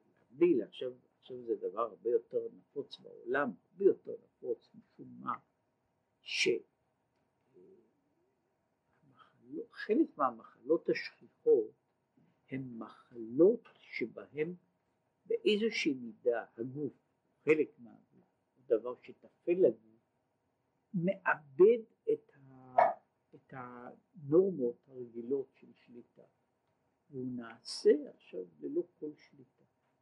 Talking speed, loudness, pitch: 80 wpm, -34 LUFS, 195 Hz